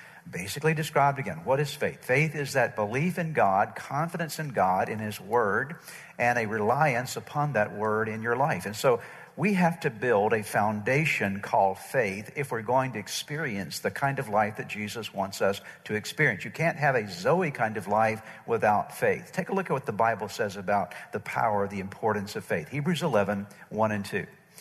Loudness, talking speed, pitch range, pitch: -28 LUFS, 200 wpm, 105-155 Hz, 125 Hz